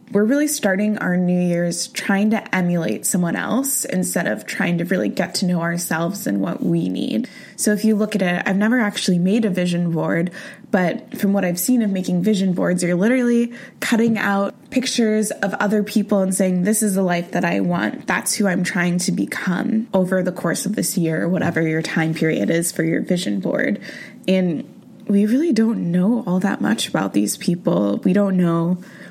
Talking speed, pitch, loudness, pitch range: 205 wpm, 190 Hz, -19 LUFS, 175-215 Hz